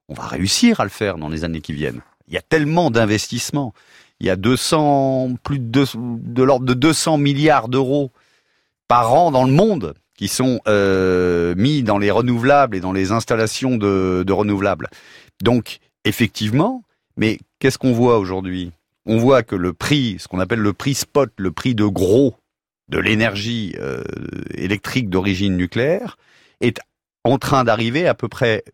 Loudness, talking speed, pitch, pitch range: -18 LUFS, 175 wpm, 115 Hz, 95-135 Hz